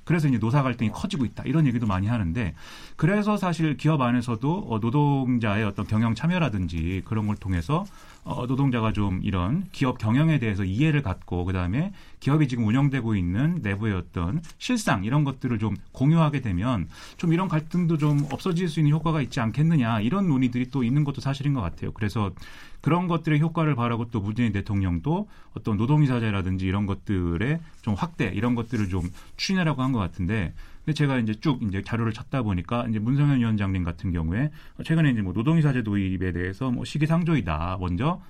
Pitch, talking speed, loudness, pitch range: 120 Hz, 410 characters per minute, -25 LUFS, 100-150 Hz